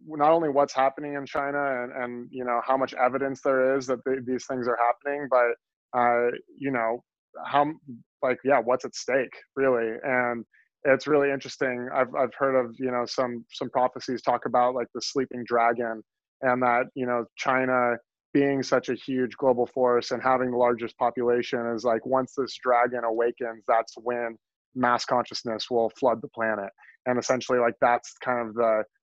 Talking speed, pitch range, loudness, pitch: 180 wpm, 120-130 Hz, -26 LUFS, 125 Hz